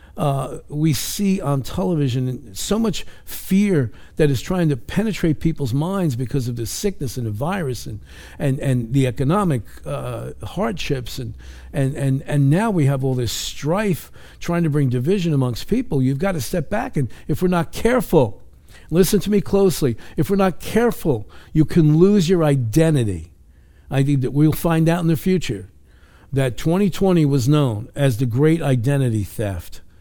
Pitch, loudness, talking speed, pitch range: 145 Hz, -20 LUFS, 170 wpm, 125-170 Hz